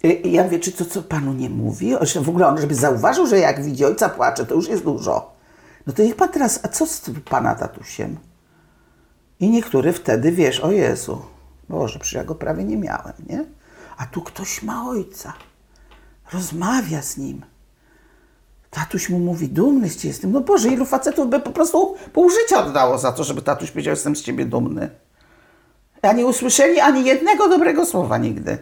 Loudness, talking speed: -19 LUFS, 190 wpm